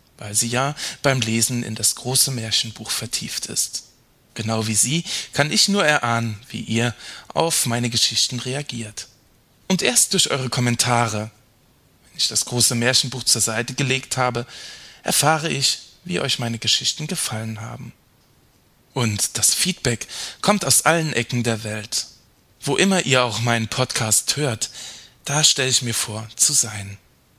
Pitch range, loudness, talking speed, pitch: 115-135 Hz, -19 LUFS, 150 wpm, 120 Hz